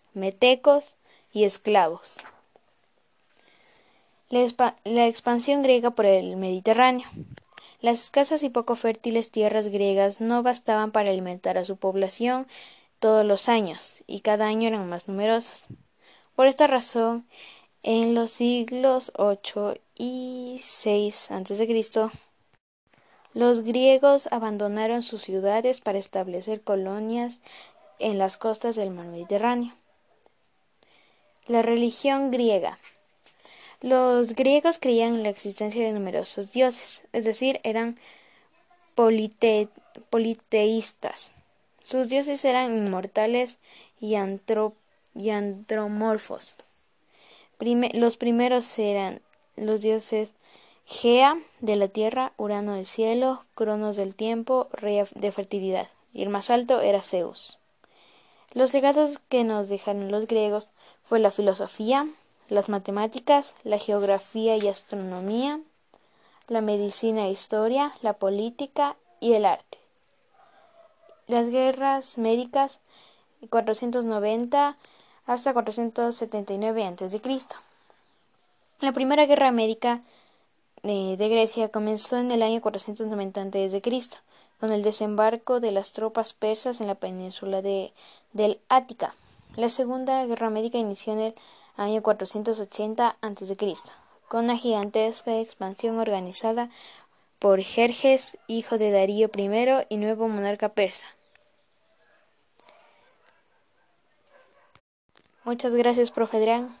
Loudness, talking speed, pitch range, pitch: -25 LUFS, 110 wpm, 210-245 Hz, 225 Hz